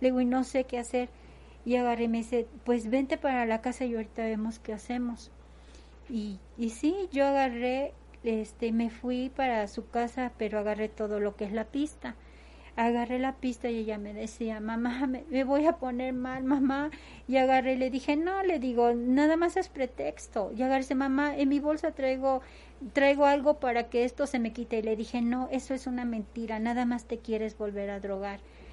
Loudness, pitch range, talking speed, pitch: -30 LUFS, 225-265 Hz, 210 wpm, 245 Hz